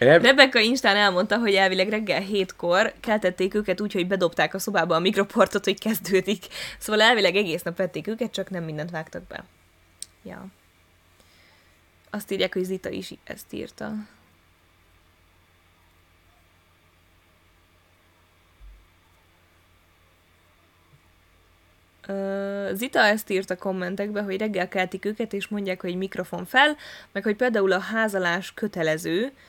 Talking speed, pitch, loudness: 120 wpm, 180 Hz, -23 LUFS